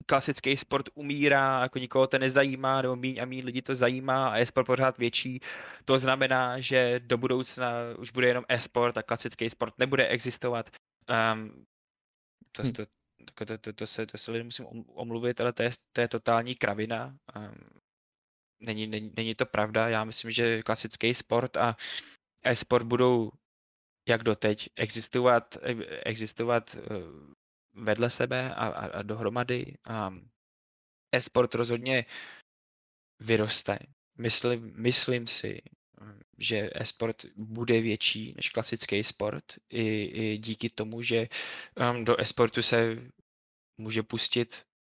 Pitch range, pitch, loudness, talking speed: 110-125 Hz, 120 Hz, -29 LUFS, 130 wpm